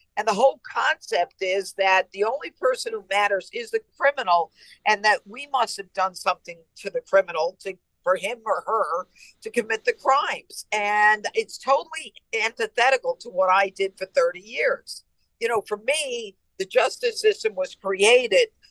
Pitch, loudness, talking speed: 240 Hz, -23 LUFS, 170 wpm